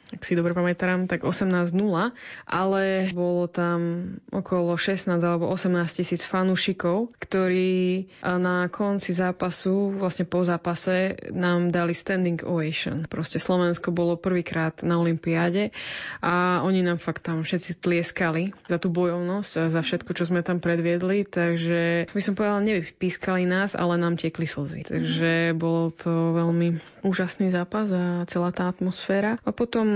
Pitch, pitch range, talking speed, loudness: 175 Hz, 170-185 Hz, 140 wpm, -25 LUFS